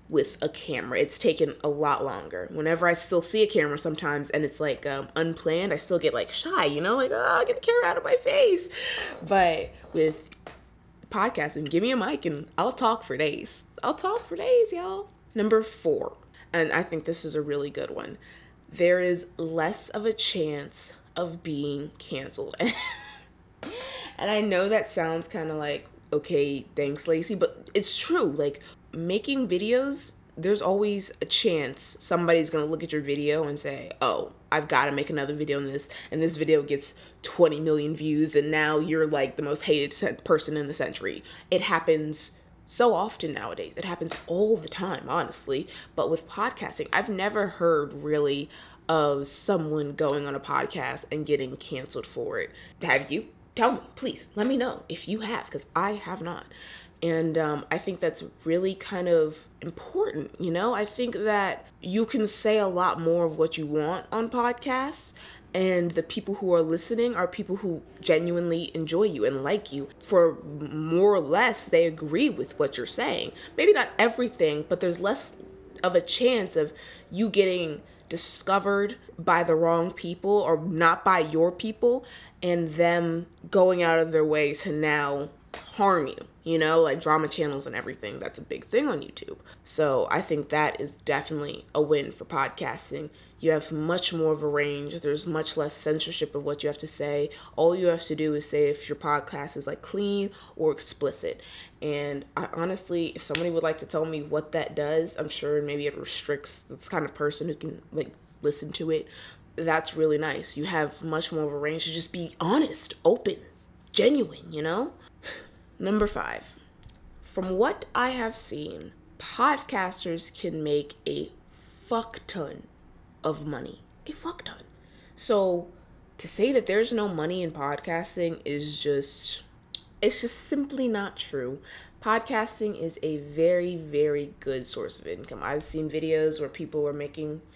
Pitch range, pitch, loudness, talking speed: 150-205 Hz, 165 Hz, -27 LUFS, 180 wpm